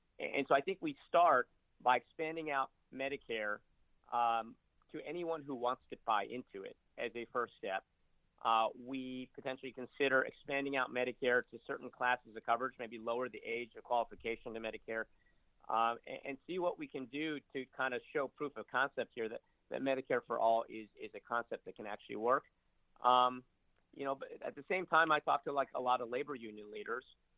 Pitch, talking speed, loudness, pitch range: 125 Hz, 195 wpm, -38 LUFS, 115-140 Hz